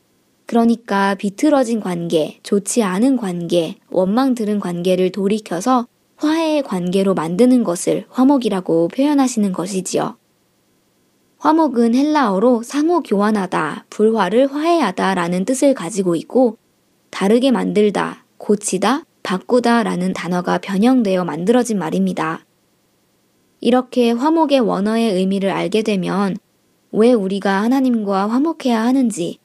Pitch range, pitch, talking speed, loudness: 190-255 Hz, 215 Hz, 285 characters per minute, -17 LUFS